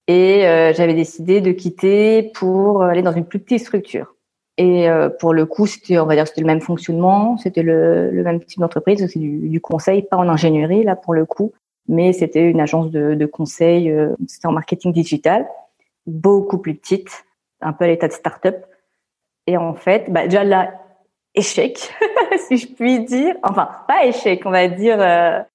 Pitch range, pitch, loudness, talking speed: 165-195 Hz, 180 Hz, -16 LUFS, 195 wpm